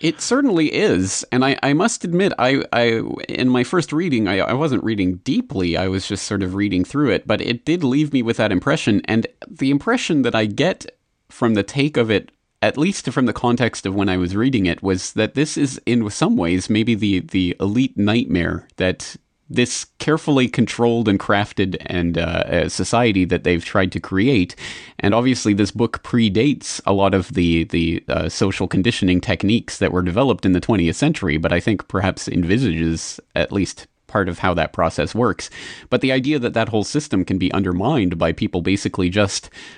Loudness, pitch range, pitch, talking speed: -19 LUFS, 95-125 Hz, 105 Hz, 200 wpm